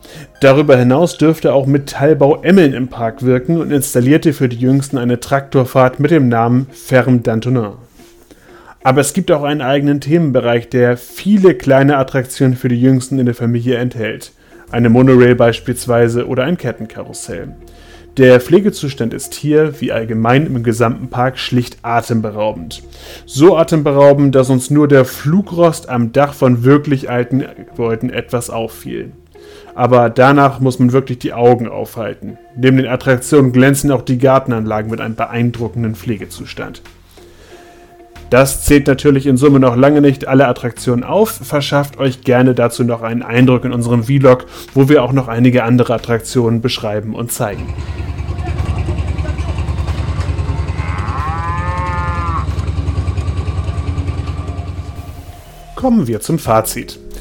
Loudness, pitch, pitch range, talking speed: -13 LUFS, 125 Hz, 110-135 Hz, 130 wpm